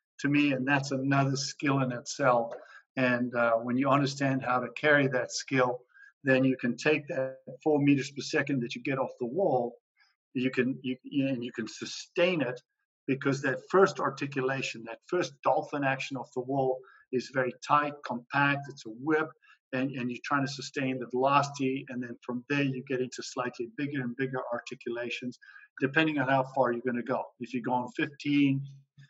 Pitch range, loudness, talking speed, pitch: 125-140 Hz, -30 LUFS, 185 wpm, 135 Hz